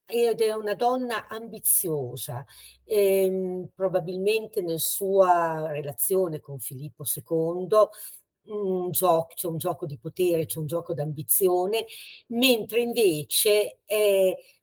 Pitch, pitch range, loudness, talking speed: 180 Hz, 160-210 Hz, -25 LUFS, 115 wpm